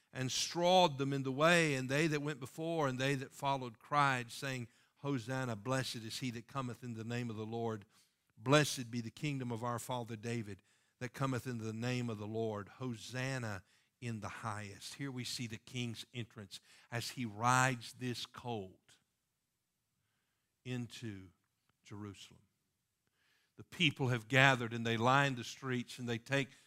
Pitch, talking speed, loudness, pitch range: 125 Hz, 165 wpm, -37 LUFS, 115-135 Hz